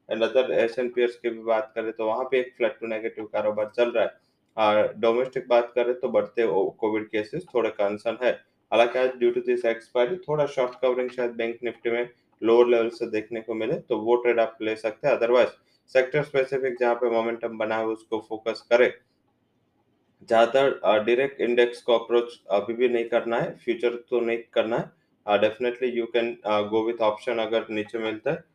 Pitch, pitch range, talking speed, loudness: 120 Hz, 110-125 Hz, 200 wpm, -25 LUFS